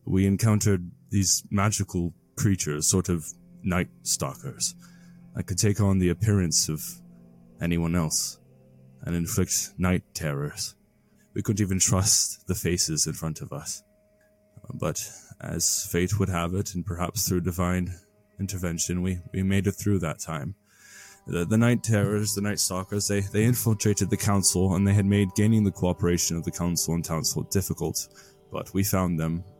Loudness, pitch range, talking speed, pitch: -26 LUFS, 85-105 Hz, 160 wpm, 95 Hz